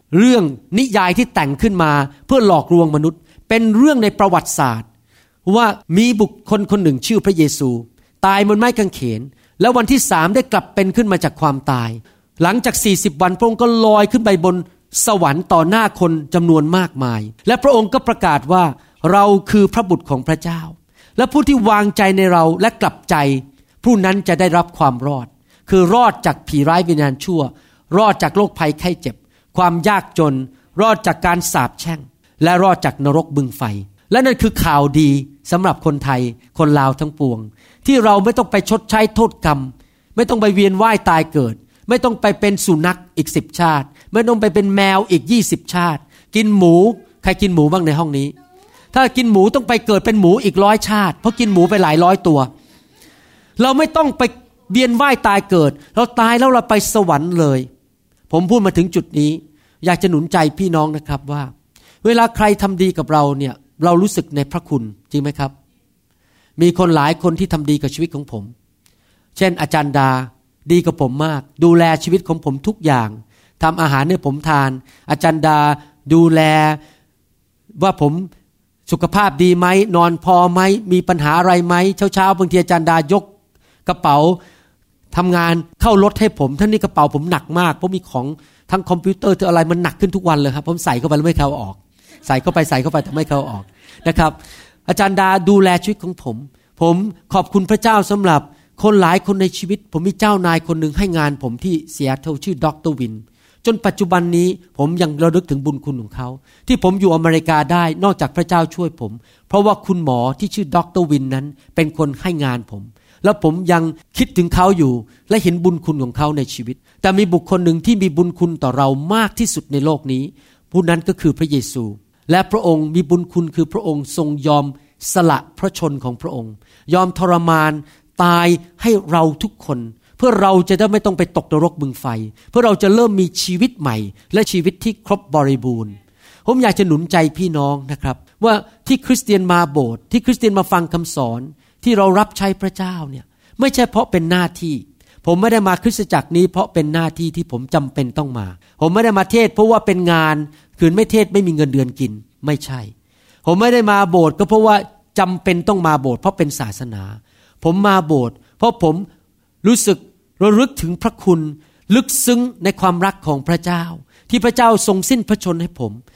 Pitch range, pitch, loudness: 145-200 Hz, 170 Hz, -15 LUFS